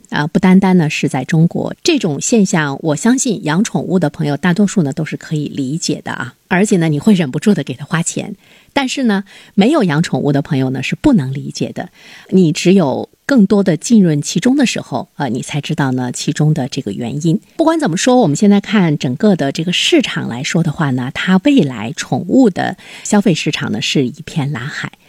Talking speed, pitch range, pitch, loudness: 310 characters per minute, 150-205 Hz, 170 Hz, -14 LUFS